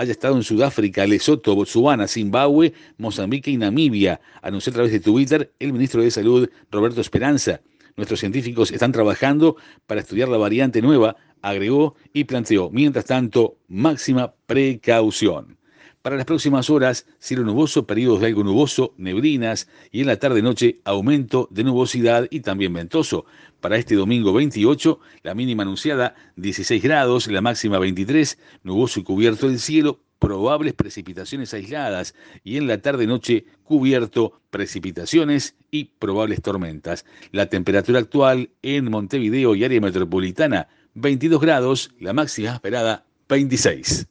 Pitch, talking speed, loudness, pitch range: 125 Hz, 135 wpm, -20 LUFS, 105-140 Hz